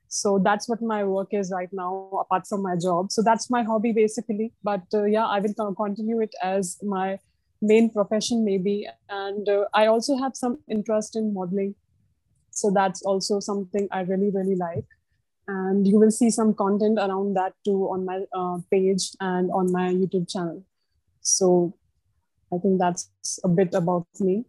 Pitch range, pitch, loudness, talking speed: 185-215 Hz, 195 Hz, -24 LUFS, 175 wpm